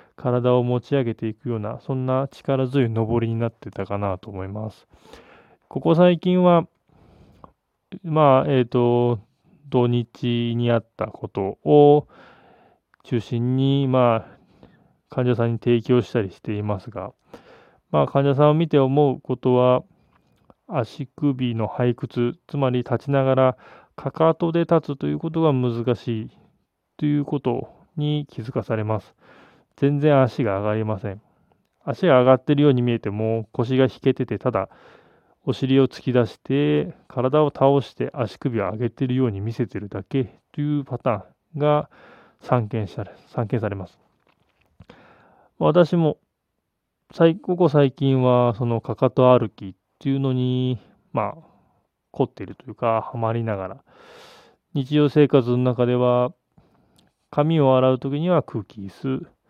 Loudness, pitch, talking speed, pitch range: -21 LUFS, 125 Hz, 265 characters per minute, 115-145 Hz